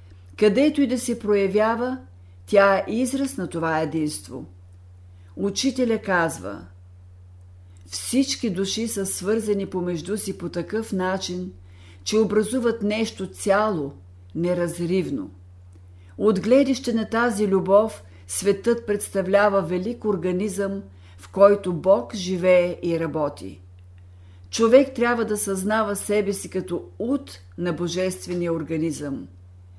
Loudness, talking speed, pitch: -23 LUFS, 105 wpm, 185 Hz